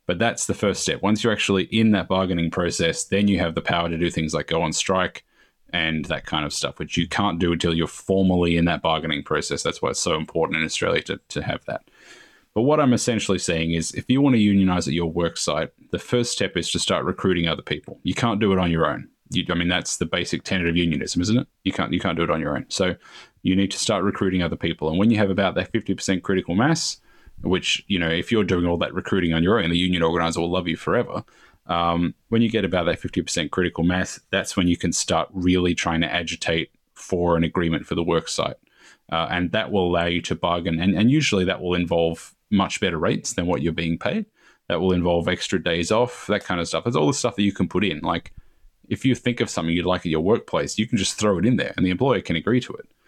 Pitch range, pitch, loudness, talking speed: 85-100 Hz, 90 Hz, -22 LUFS, 260 wpm